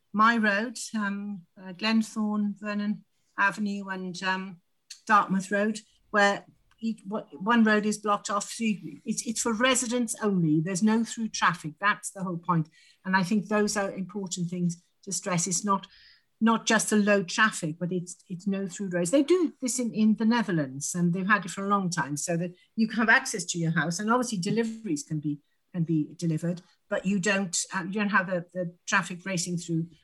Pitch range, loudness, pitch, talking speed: 180-215 Hz, -27 LUFS, 200 Hz, 200 wpm